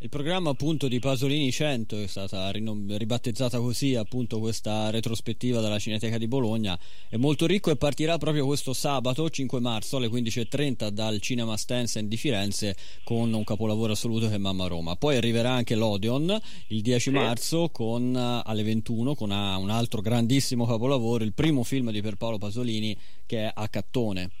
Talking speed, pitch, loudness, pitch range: 170 wpm, 115 Hz, -28 LUFS, 110-135 Hz